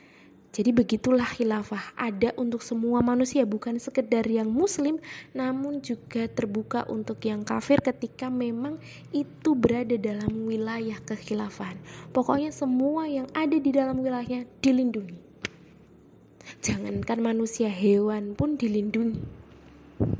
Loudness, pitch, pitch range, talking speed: -27 LUFS, 235 Hz, 220-260 Hz, 110 wpm